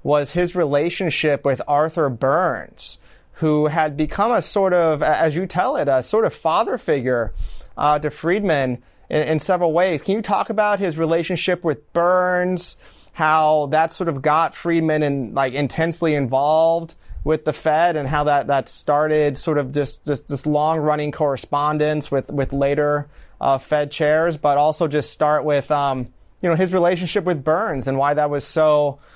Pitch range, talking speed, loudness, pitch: 145-170 Hz, 180 wpm, -19 LUFS, 155 Hz